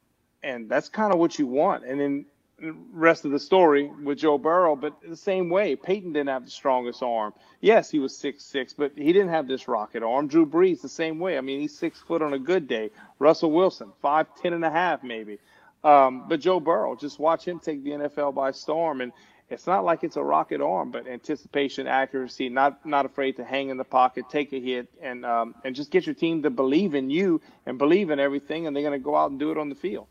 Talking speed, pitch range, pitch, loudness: 245 wpm, 135-165 Hz, 145 Hz, -25 LUFS